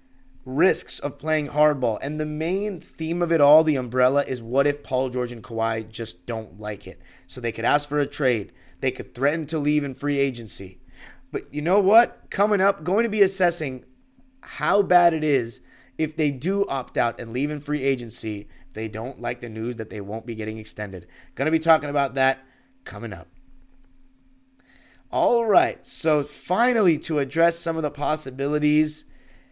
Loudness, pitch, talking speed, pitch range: -23 LUFS, 140 Hz, 190 wpm, 120-160 Hz